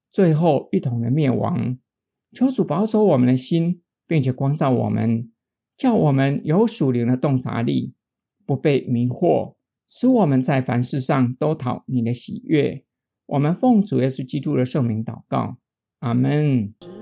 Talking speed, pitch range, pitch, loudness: 220 characters per minute, 125-165 Hz, 135 Hz, -20 LUFS